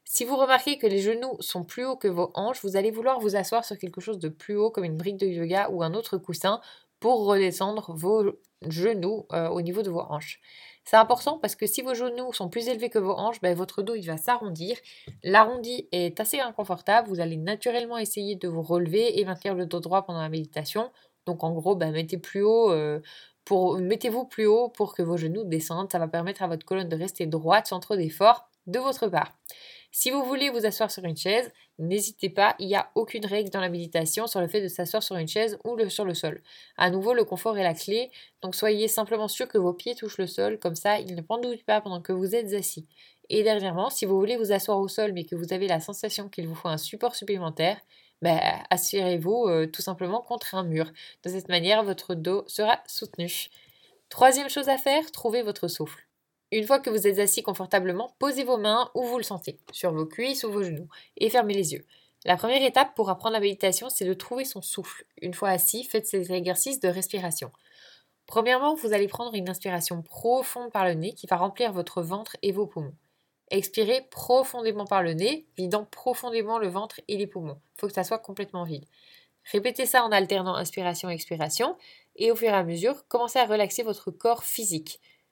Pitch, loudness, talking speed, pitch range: 200 Hz, -26 LUFS, 220 wpm, 180-225 Hz